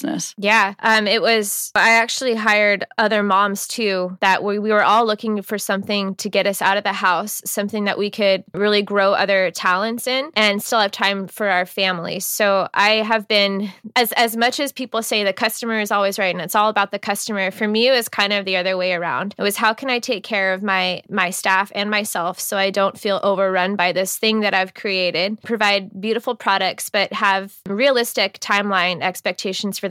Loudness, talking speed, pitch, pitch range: -18 LUFS, 210 wpm, 205 Hz, 195-220 Hz